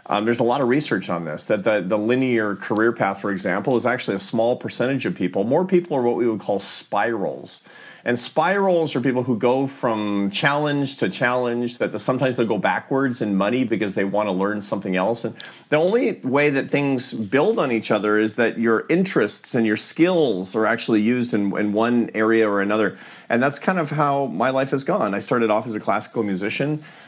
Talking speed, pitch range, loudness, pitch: 215 wpm, 105-135 Hz, -21 LUFS, 120 Hz